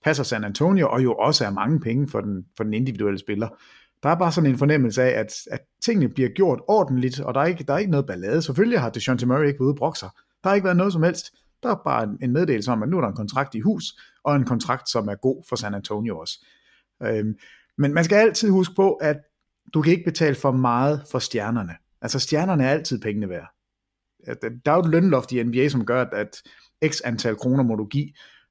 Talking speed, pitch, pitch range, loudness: 240 wpm, 135 Hz, 120-160 Hz, -22 LUFS